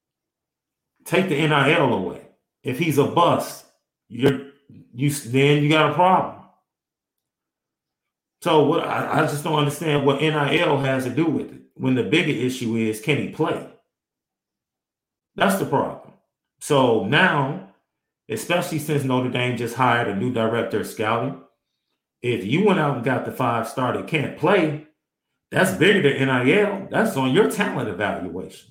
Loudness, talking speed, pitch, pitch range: -21 LUFS, 155 wpm, 140 Hz, 125-155 Hz